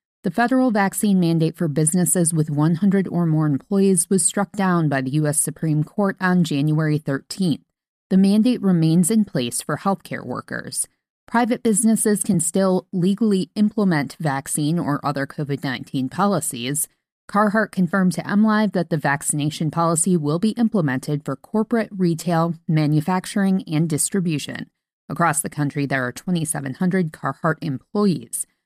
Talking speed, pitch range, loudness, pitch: 140 wpm, 150-195 Hz, -20 LUFS, 175 Hz